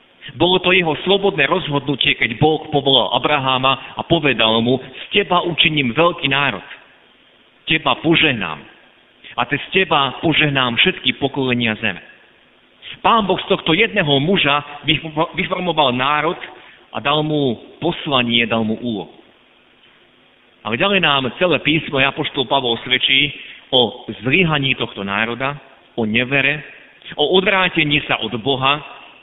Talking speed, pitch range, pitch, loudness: 125 wpm, 130-165 Hz, 145 Hz, -16 LUFS